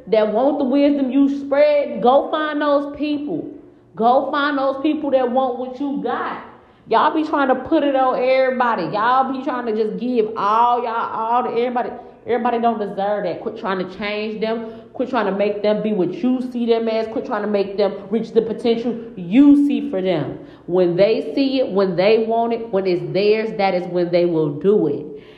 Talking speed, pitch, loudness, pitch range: 210 wpm, 235 Hz, -19 LUFS, 205-270 Hz